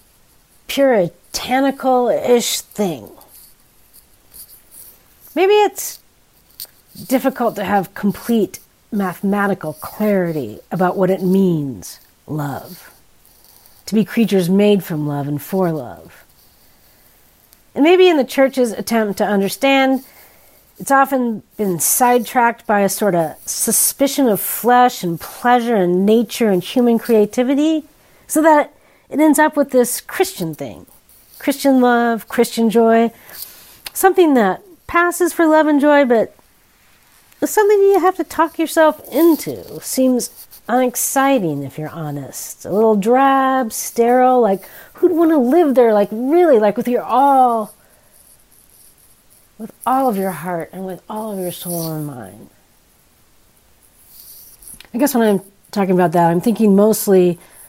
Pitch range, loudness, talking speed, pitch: 190-270 Hz, -16 LUFS, 130 wpm, 230 Hz